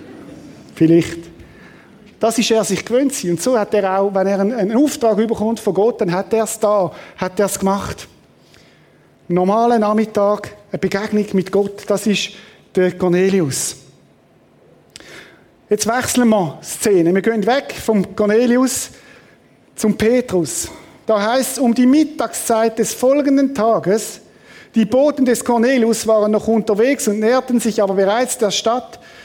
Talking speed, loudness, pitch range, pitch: 150 wpm, -16 LUFS, 195-235 Hz, 215 Hz